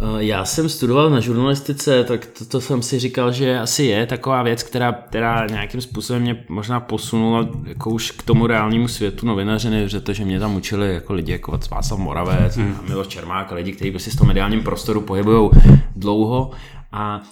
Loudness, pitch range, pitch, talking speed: -19 LUFS, 105-125 Hz, 115 Hz, 190 wpm